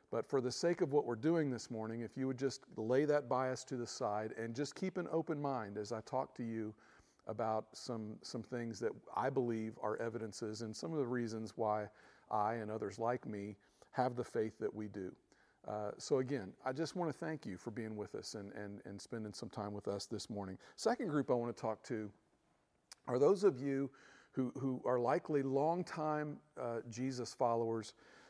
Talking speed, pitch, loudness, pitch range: 210 wpm, 120 Hz, -40 LUFS, 110-135 Hz